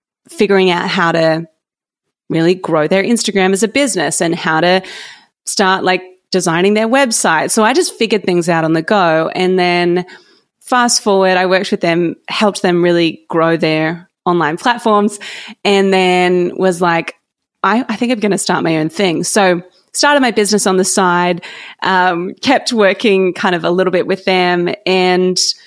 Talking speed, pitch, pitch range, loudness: 175 wpm, 185 Hz, 175-210 Hz, -13 LUFS